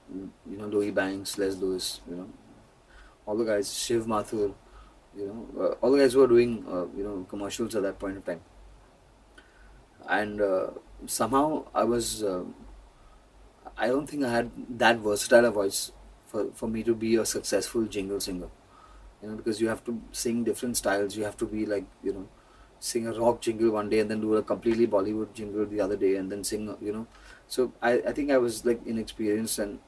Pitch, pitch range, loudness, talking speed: 110 Hz, 100-115 Hz, -28 LUFS, 200 wpm